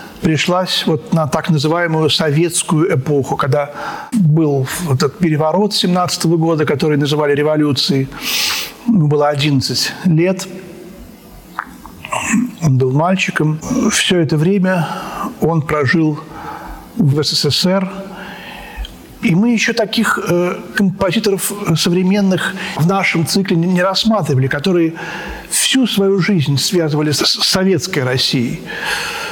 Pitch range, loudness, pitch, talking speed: 150-190 Hz, -15 LUFS, 170 Hz, 100 wpm